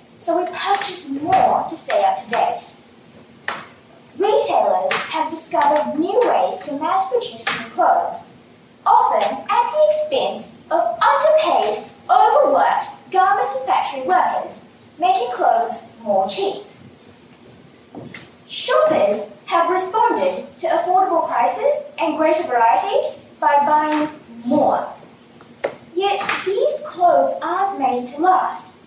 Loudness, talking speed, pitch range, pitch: -18 LUFS, 110 wpm, 290-370 Hz, 320 Hz